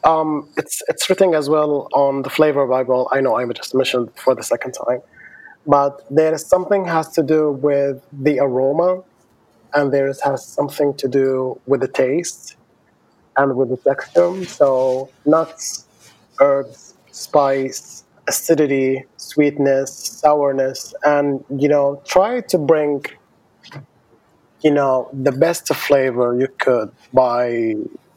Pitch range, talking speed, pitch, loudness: 135-155 Hz, 140 wpm, 140 Hz, -18 LUFS